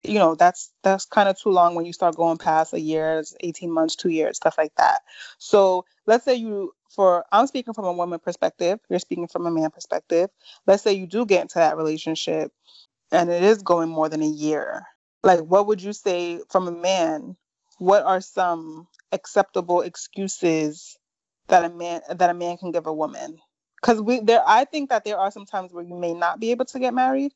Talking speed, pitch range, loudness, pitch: 215 wpm, 170-205 Hz, -22 LUFS, 180 Hz